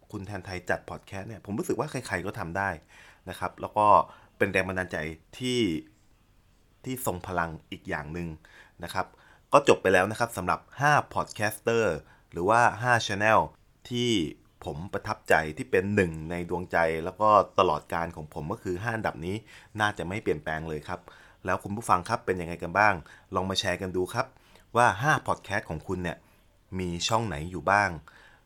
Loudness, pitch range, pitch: -28 LUFS, 85-105 Hz, 95 Hz